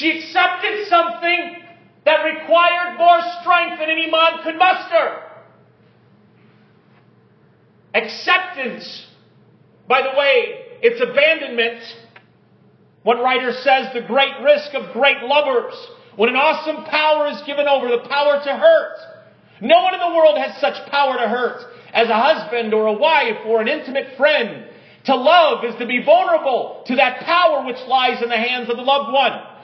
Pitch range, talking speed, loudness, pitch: 255-340 Hz, 155 wpm, -16 LUFS, 295 Hz